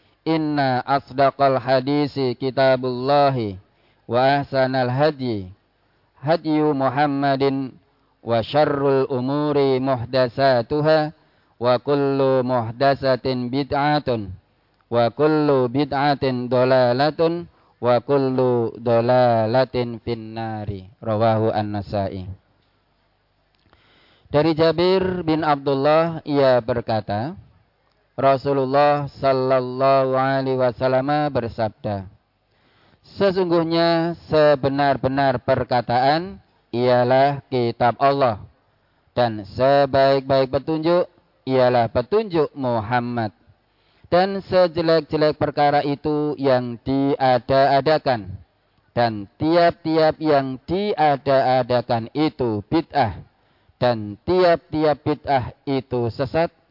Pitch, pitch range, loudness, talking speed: 130 Hz, 120-145 Hz, -20 LUFS, 70 wpm